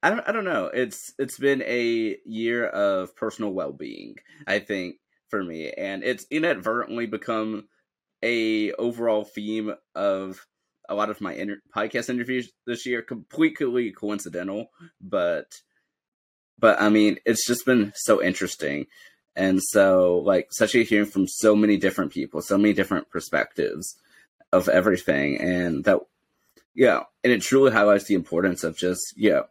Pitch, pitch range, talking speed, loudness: 105 Hz, 95-120 Hz, 160 wpm, -24 LUFS